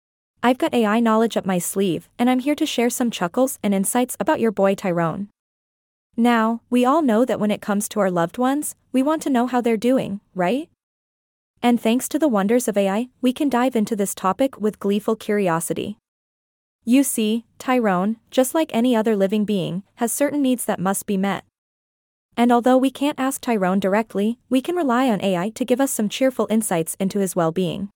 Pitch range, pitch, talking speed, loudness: 195-255 Hz, 225 Hz, 200 wpm, -21 LUFS